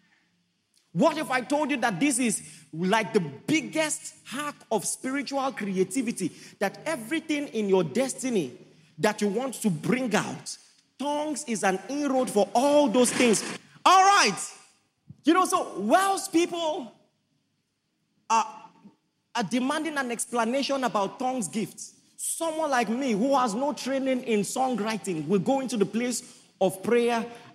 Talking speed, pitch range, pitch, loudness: 140 wpm, 210-280 Hz, 245 Hz, -26 LUFS